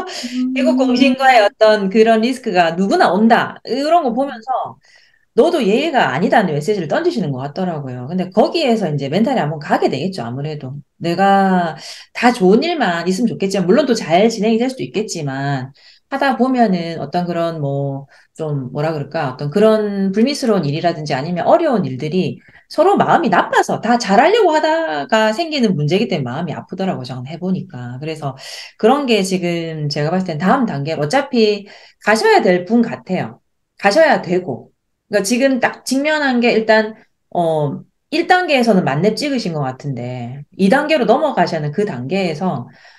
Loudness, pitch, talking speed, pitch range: -16 LUFS, 195 Hz, 350 characters per minute, 160-235 Hz